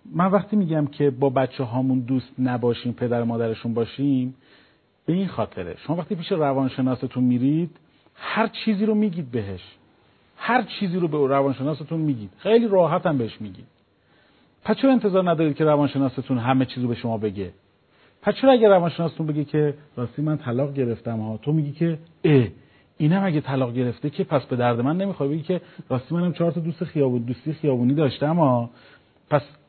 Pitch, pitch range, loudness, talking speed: 140 Hz, 125-170 Hz, -23 LUFS, 170 wpm